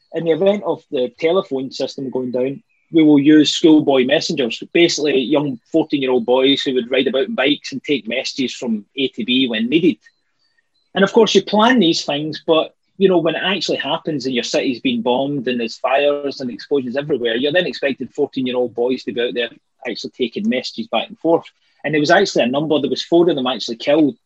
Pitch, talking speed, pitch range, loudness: 145 Hz, 225 wpm, 130-170 Hz, -17 LUFS